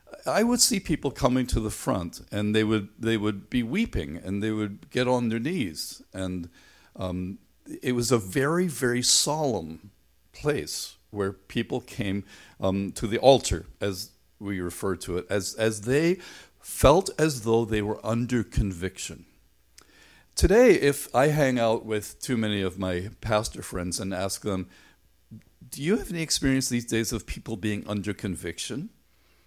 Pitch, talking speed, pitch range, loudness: 110 Hz, 165 wpm, 95-125 Hz, -26 LUFS